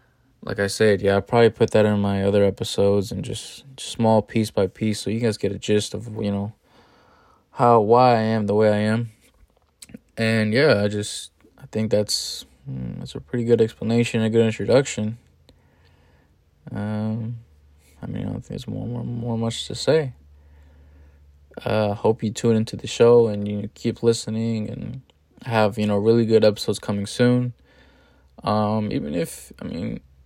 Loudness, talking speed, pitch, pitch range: -21 LUFS, 180 wpm, 110 Hz, 100-115 Hz